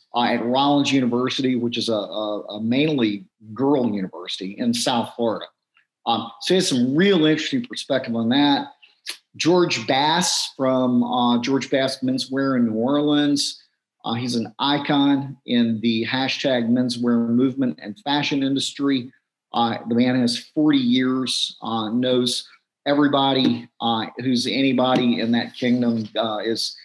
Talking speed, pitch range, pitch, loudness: 145 wpm, 120-140 Hz, 125 Hz, -21 LUFS